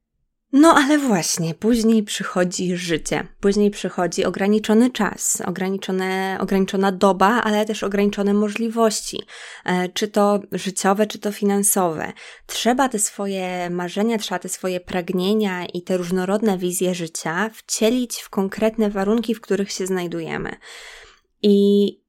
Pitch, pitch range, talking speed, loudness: 200 Hz, 185-215 Hz, 120 wpm, -20 LUFS